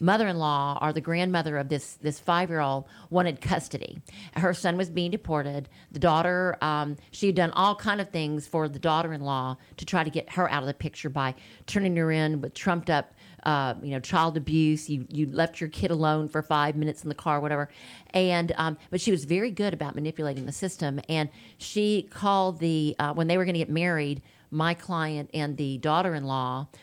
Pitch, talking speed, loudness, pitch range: 155 Hz, 200 wpm, -27 LUFS, 145-175 Hz